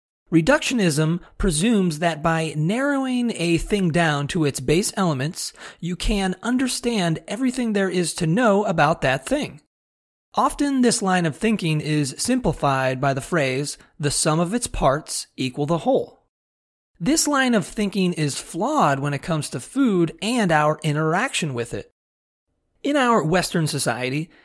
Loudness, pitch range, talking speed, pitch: -21 LUFS, 150-220 Hz, 150 wpm, 170 Hz